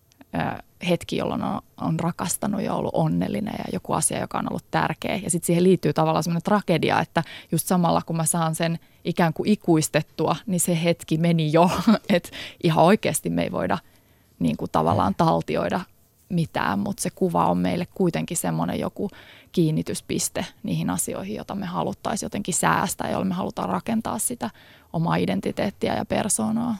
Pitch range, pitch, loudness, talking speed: 160-185 Hz, 170 Hz, -24 LUFS, 160 wpm